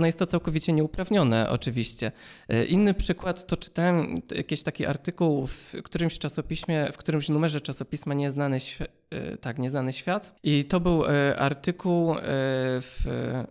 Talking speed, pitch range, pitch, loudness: 135 wpm, 140-175 Hz, 155 Hz, -27 LUFS